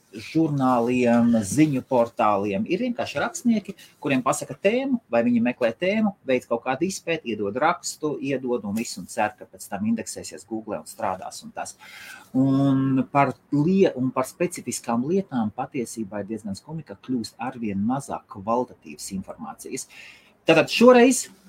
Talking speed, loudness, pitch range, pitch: 125 wpm, -23 LUFS, 115-175 Hz, 130 Hz